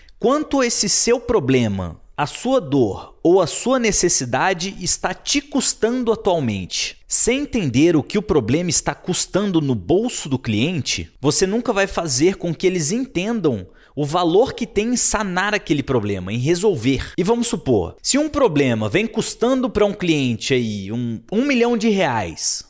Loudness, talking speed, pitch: -19 LUFS, 165 wpm, 185 Hz